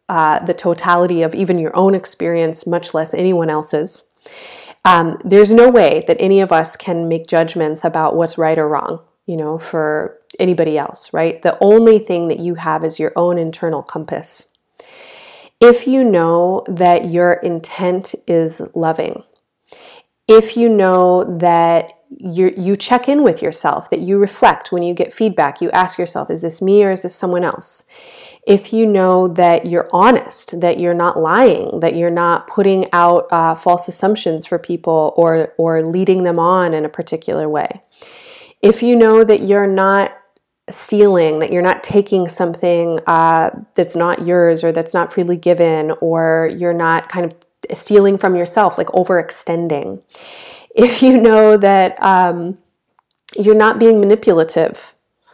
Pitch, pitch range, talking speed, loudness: 175 Hz, 165-200 Hz, 165 wpm, -13 LUFS